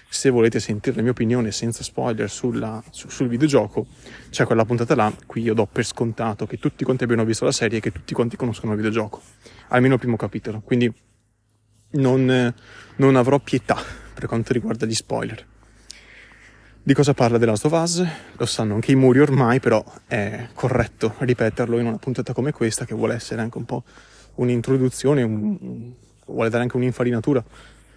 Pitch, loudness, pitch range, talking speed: 120 Hz, -21 LUFS, 110-130 Hz, 180 wpm